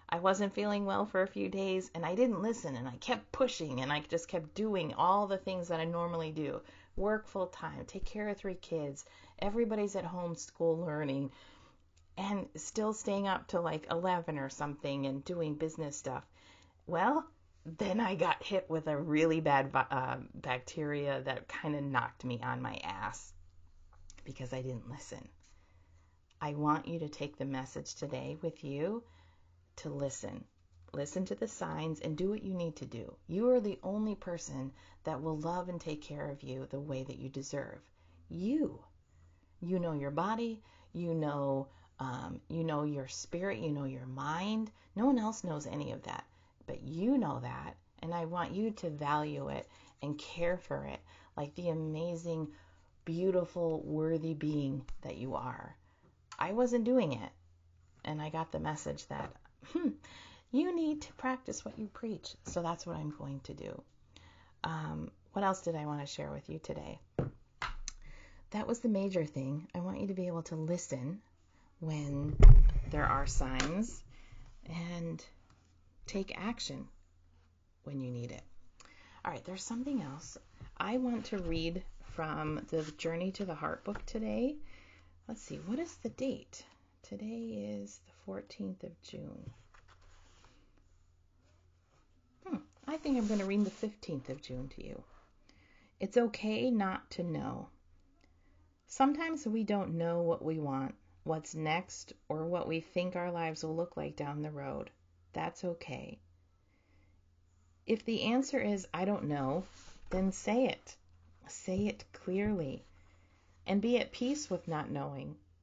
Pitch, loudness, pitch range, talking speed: 155 Hz, -37 LUFS, 115-190 Hz, 165 wpm